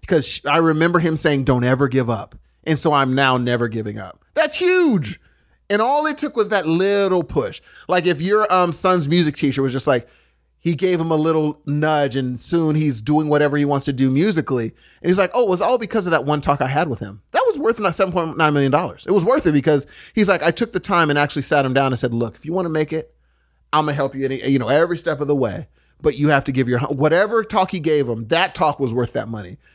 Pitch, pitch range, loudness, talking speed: 150 Hz, 135-180 Hz, -18 LUFS, 260 wpm